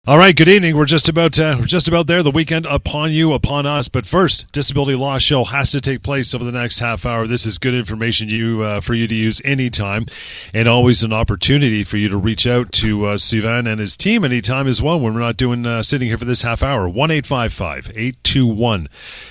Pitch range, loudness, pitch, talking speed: 115-145 Hz, -14 LUFS, 125 Hz, 225 wpm